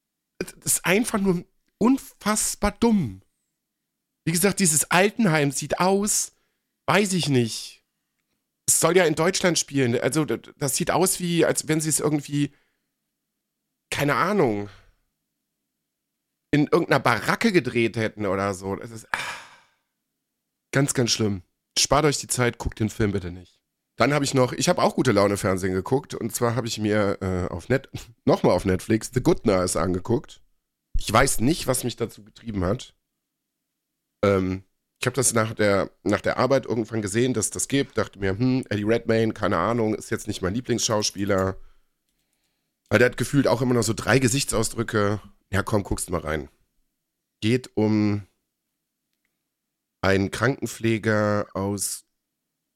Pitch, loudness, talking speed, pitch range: 115 Hz, -23 LUFS, 155 wpm, 100-140 Hz